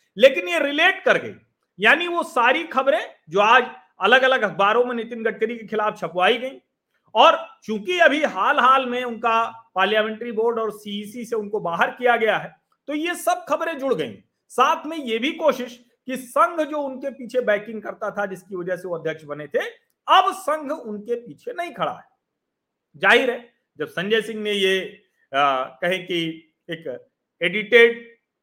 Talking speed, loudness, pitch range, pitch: 175 wpm, -21 LUFS, 210-290 Hz, 235 Hz